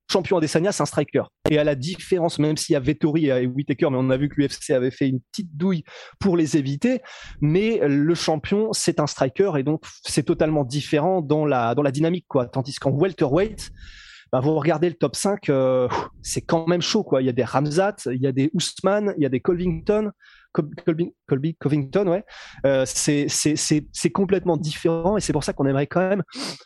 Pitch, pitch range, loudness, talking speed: 155 Hz, 145-180 Hz, -22 LUFS, 220 wpm